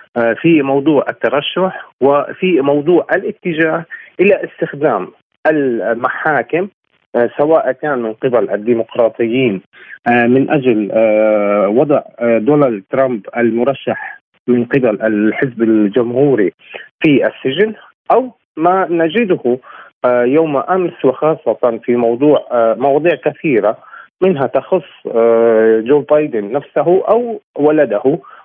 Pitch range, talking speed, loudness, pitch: 115-160 Hz, 90 wpm, -14 LUFS, 135 Hz